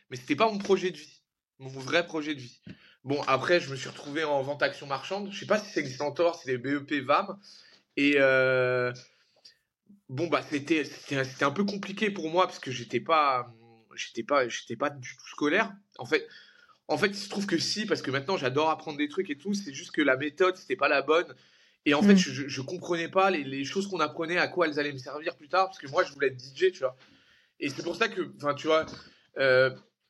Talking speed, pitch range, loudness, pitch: 240 wpm, 135-185 Hz, -28 LUFS, 155 Hz